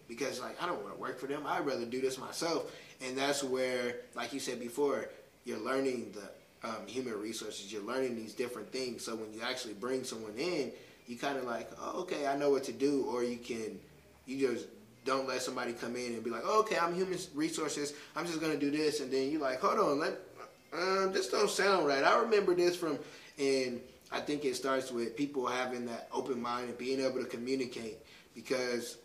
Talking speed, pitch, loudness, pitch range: 220 wpm, 130 Hz, -35 LUFS, 125-145 Hz